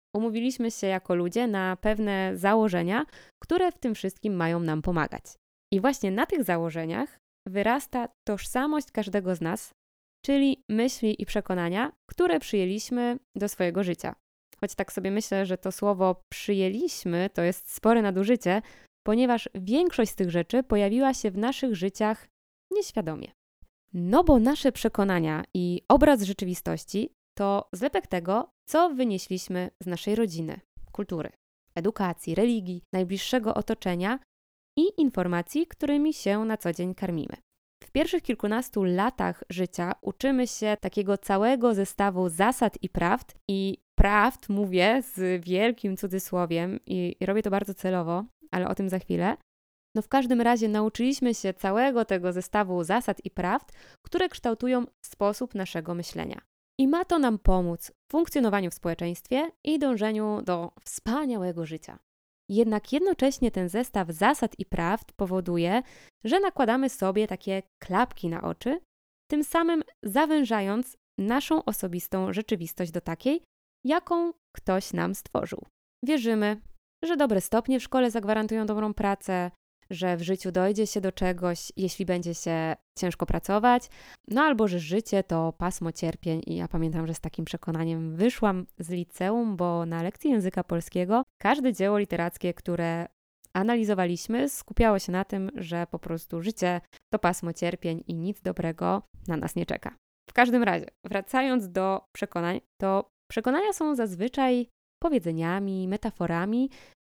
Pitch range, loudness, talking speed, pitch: 180-245 Hz, -27 LUFS, 140 wpm, 205 Hz